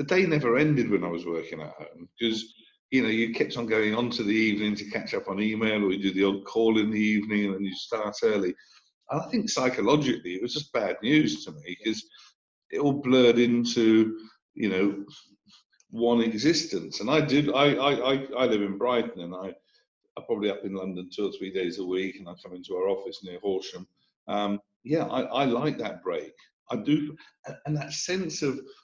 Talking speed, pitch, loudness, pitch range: 215 wpm, 115 Hz, -27 LUFS, 105-150 Hz